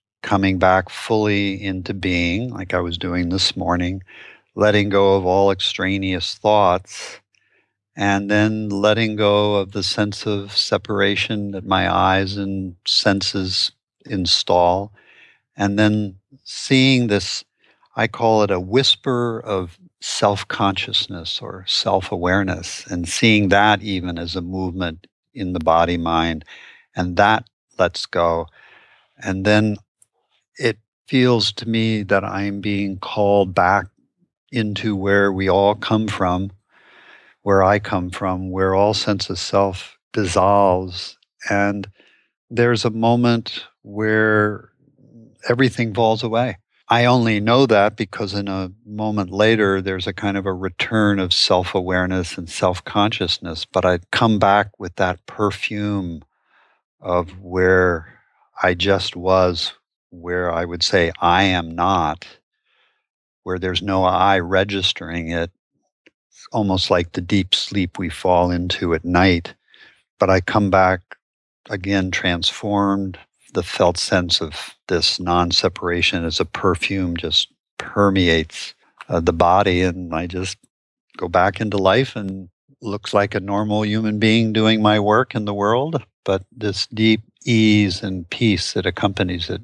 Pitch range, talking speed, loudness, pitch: 90-105 Hz, 135 wpm, -19 LUFS, 100 Hz